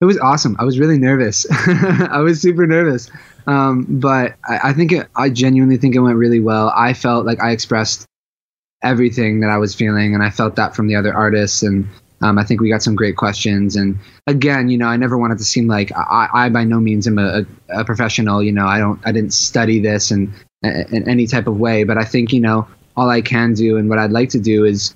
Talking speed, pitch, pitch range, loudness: 245 wpm, 115 Hz, 105-125 Hz, -15 LUFS